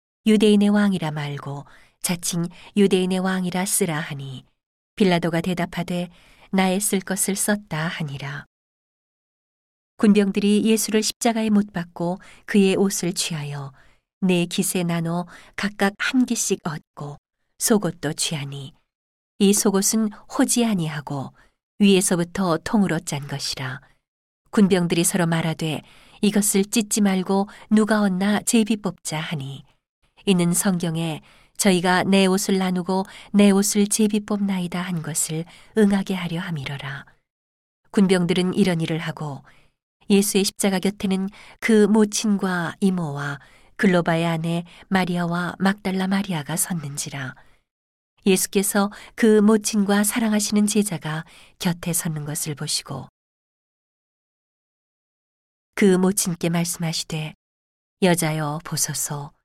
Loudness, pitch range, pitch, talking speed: -21 LUFS, 160-200 Hz, 185 Hz, 250 characters per minute